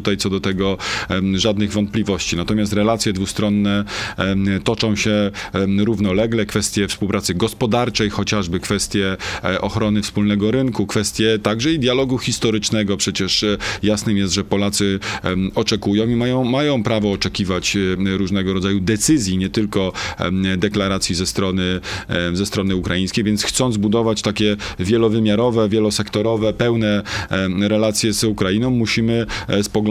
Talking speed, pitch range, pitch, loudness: 120 wpm, 95-110 Hz, 105 Hz, -18 LUFS